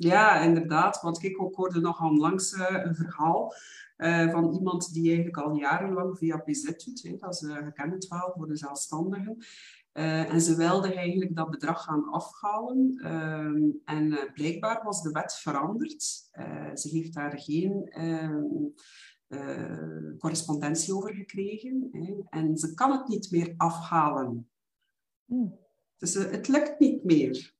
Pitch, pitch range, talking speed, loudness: 165 Hz, 155-195 Hz, 130 wpm, -29 LUFS